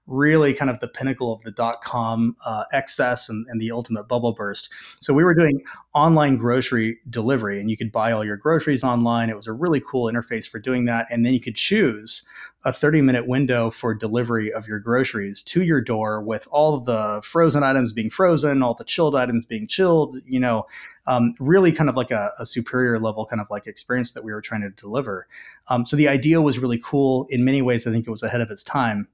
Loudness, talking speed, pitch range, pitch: -21 LUFS, 230 wpm, 115-140 Hz, 120 Hz